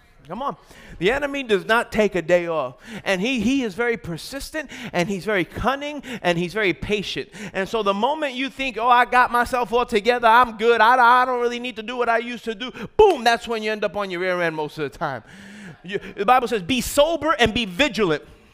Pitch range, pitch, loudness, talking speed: 195-250 Hz, 230 Hz, -21 LUFS, 235 wpm